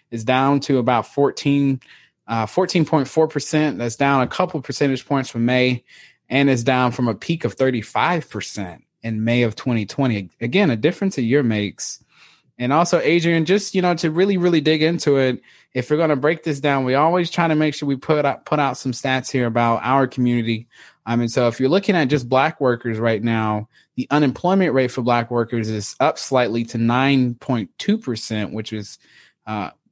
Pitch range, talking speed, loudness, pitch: 120-155 Hz, 190 wpm, -19 LUFS, 130 Hz